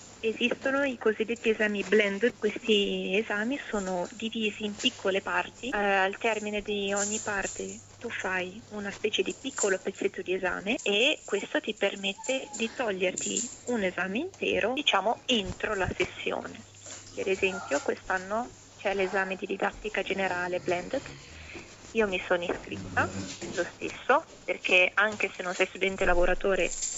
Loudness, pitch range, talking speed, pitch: -29 LUFS, 190-235 Hz, 135 wpm, 210 Hz